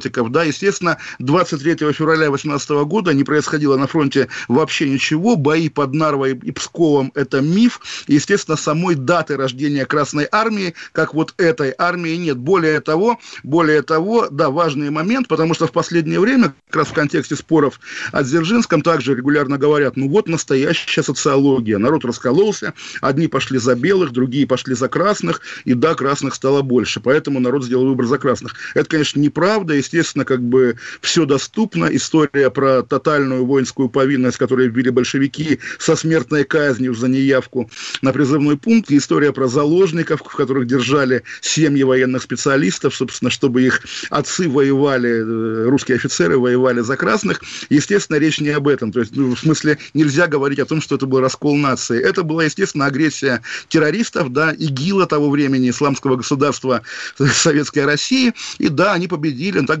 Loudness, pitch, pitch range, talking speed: -16 LUFS, 145 Hz, 135-160 Hz, 160 wpm